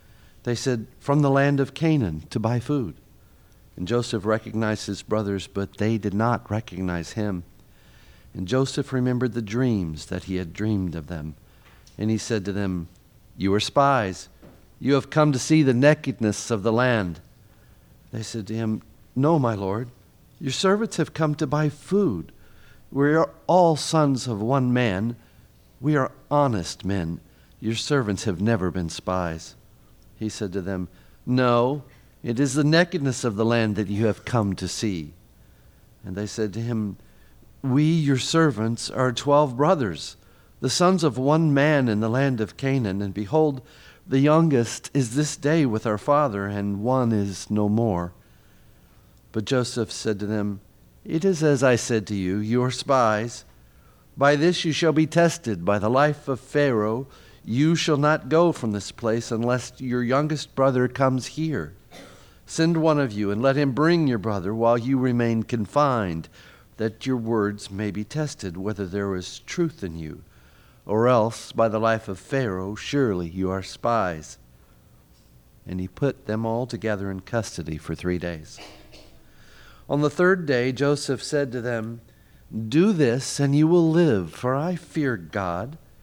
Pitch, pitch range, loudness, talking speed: 115 Hz, 100-140 Hz, -23 LUFS, 165 wpm